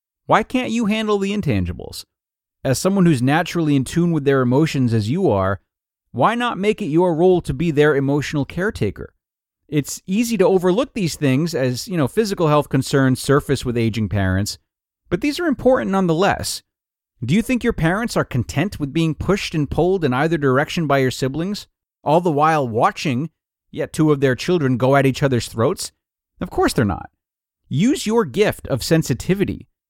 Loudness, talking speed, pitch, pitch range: -19 LUFS, 185 wpm, 150 Hz, 130-185 Hz